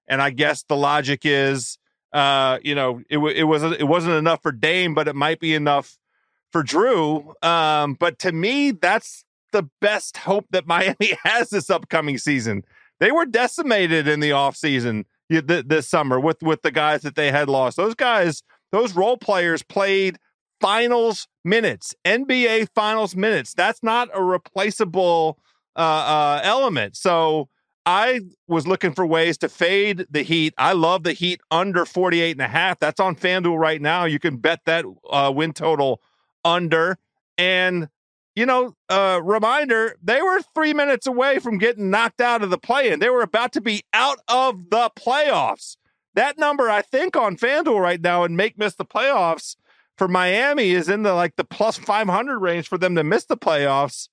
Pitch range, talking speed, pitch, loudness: 155-215 Hz, 180 wpm, 175 Hz, -20 LUFS